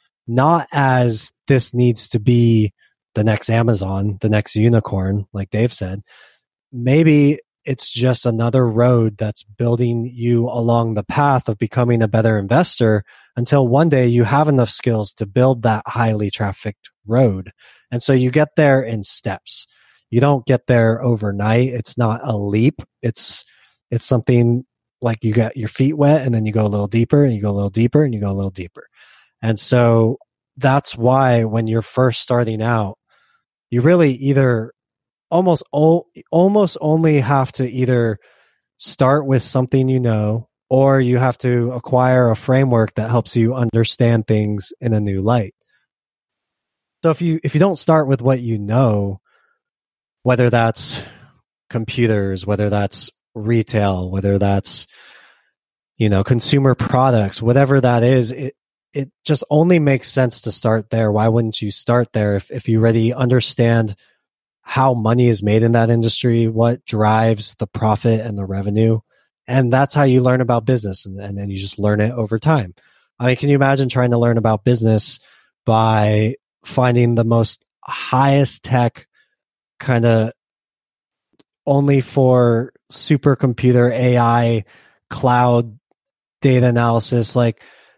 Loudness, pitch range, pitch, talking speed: -16 LUFS, 110-130 Hz, 120 Hz, 155 wpm